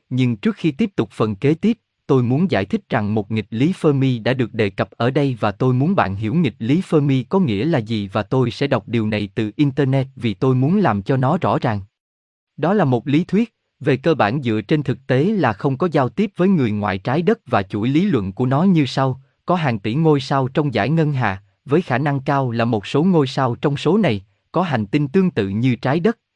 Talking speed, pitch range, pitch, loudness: 250 wpm, 115-155 Hz, 135 Hz, -19 LUFS